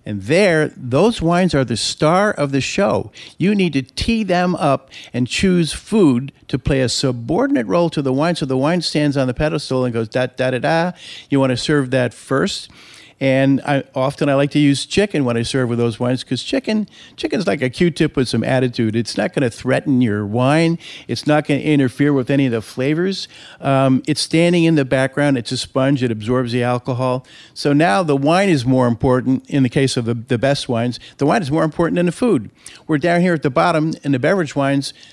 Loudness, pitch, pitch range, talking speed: -17 LUFS, 140 Hz, 125-160 Hz, 225 wpm